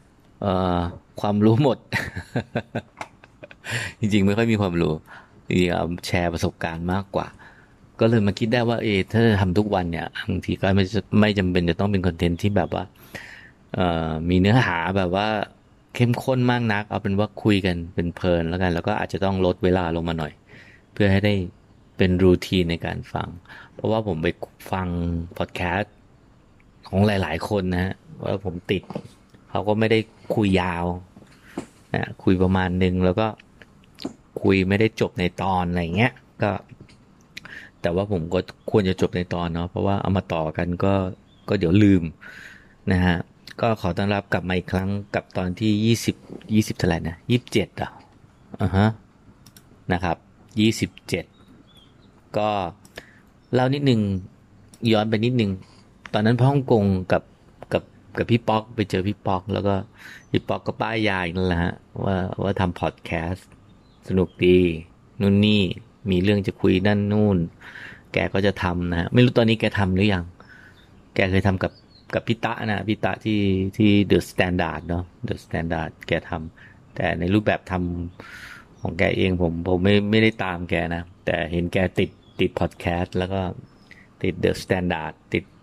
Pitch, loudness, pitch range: 95 Hz, -23 LUFS, 90-105 Hz